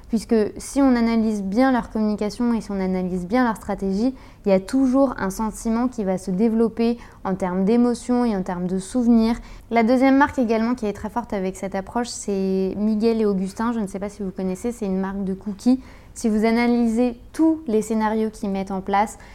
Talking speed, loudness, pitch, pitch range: 215 wpm, -22 LUFS, 220 Hz, 195-240 Hz